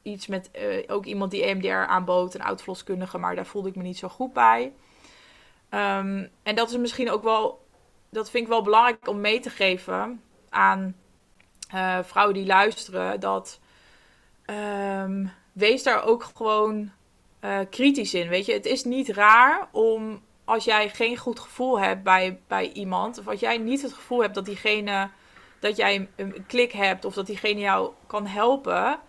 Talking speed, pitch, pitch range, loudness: 175 wpm, 205 Hz, 190-230 Hz, -24 LUFS